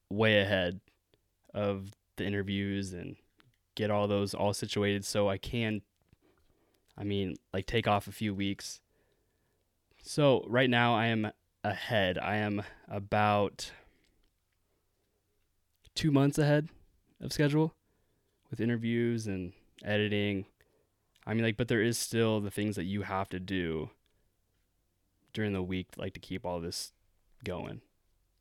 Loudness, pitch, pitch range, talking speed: -32 LUFS, 100 Hz, 95-110 Hz, 135 wpm